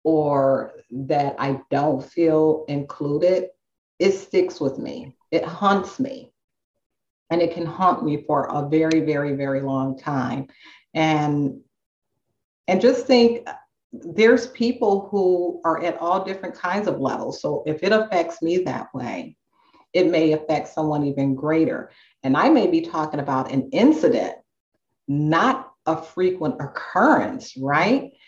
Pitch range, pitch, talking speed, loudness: 145-190 Hz, 160 Hz, 140 wpm, -21 LUFS